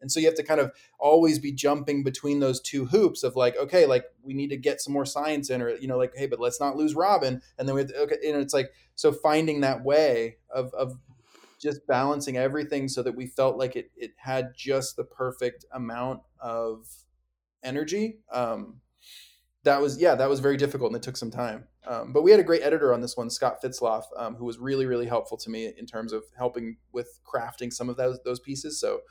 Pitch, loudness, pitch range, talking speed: 135 Hz, -26 LUFS, 125-150 Hz, 235 wpm